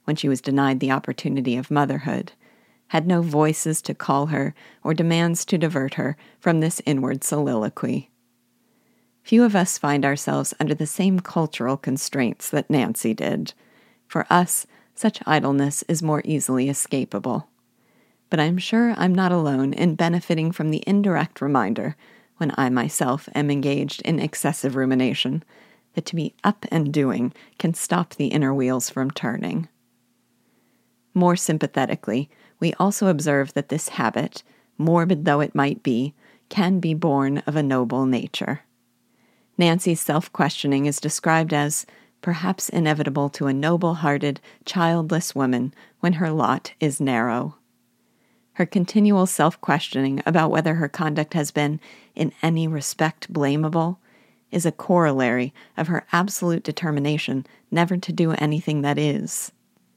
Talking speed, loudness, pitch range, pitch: 145 wpm, -22 LUFS, 140-170 Hz, 155 Hz